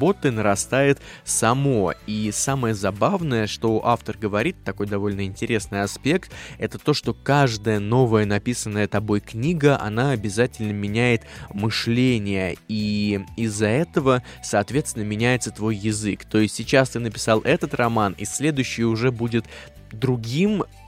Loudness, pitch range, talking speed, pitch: -22 LUFS, 105-125 Hz, 125 wpm, 110 Hz